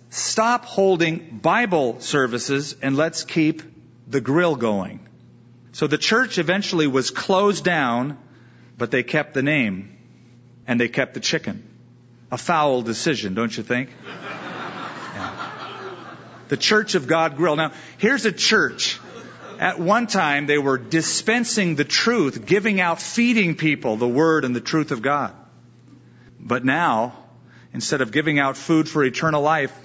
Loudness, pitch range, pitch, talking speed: -21 LUFS, 125-175 Hz, 145 Hz, 145 wpm